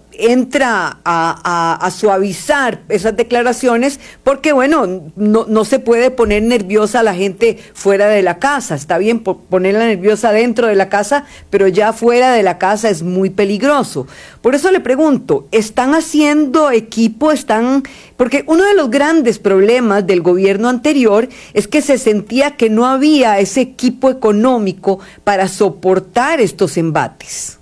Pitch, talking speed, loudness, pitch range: 225 Hz, 150 wpm, -13 LUFS, 200-260 Hz